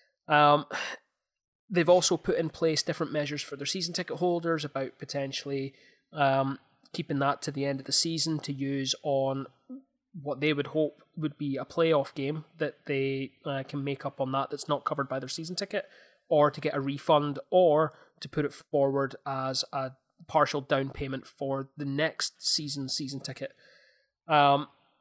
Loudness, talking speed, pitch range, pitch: -29 LUFS, 175 wpm, 135-160 Hz, 145 Hz